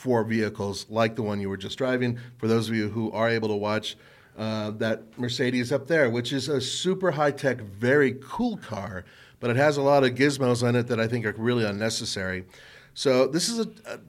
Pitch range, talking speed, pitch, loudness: 110-135 Hz, 220 wpm, 120 Hz, -26 LUFS